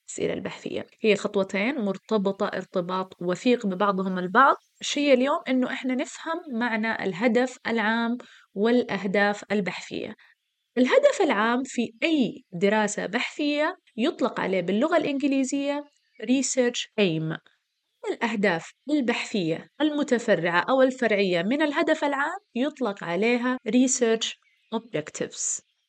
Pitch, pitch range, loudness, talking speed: 240 Hz, 205-275 Hz, -25 LUFS, 100 wpm